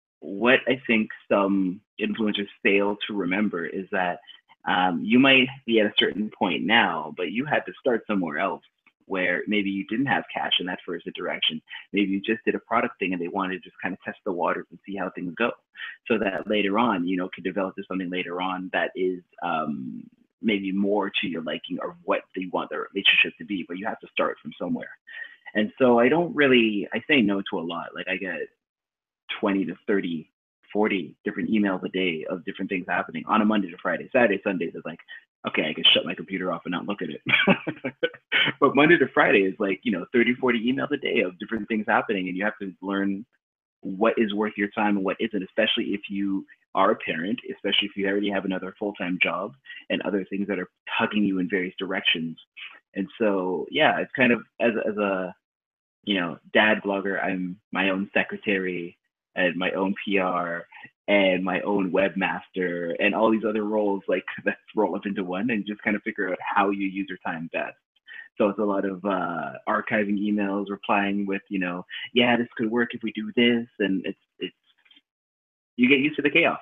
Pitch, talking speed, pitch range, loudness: 100 Hz, 210 wpm, 95-110 Hz, -25 LUFS